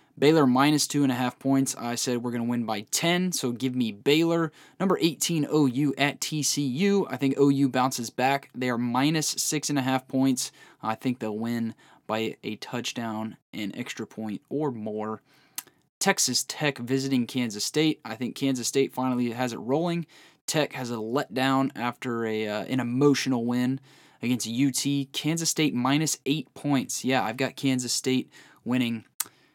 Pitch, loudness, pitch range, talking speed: 130 Hz, -26 LUFS, 120-145 Hz, 175 wpm